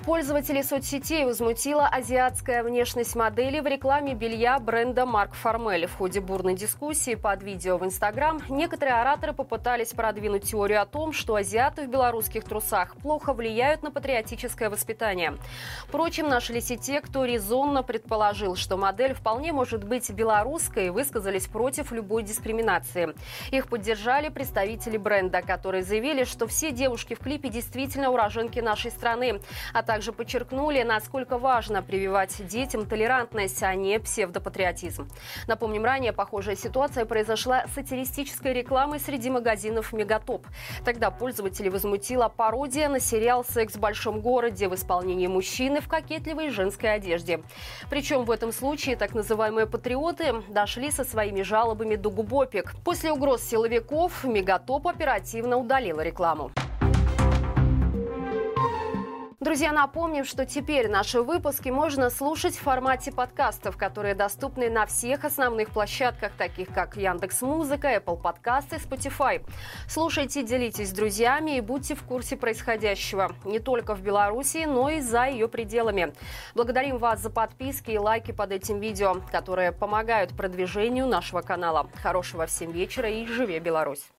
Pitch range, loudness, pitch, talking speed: 210-265 Hz, -27 LUFS, 230 Hz, 135 wpm